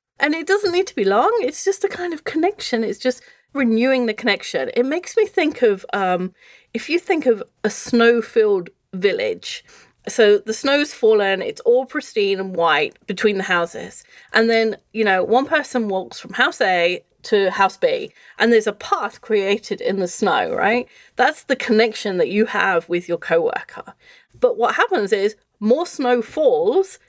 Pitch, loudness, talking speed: 245 Hz, -19 LUFS, 180 wpm